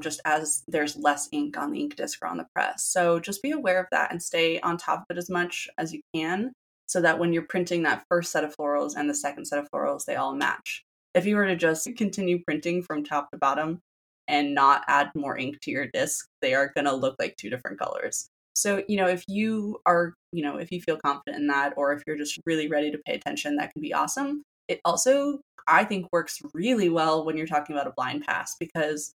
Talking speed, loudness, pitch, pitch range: 245 wpm, -27 LUFS, 165 Hz, 150-190 Hz